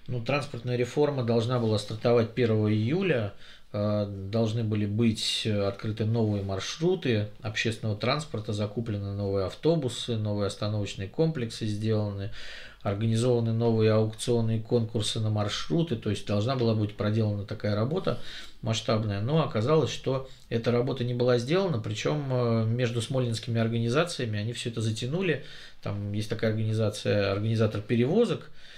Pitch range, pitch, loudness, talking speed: 105-125 Hz, 115 Hz, -28 LUFS, 125 wpm